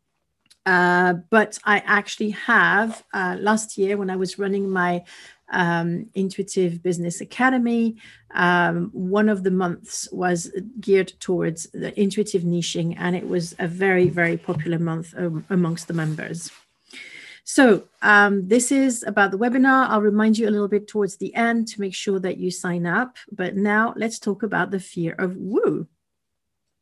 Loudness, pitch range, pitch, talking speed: -21 LUFS, 175-210 Hz, 195 Hz, 160 wpm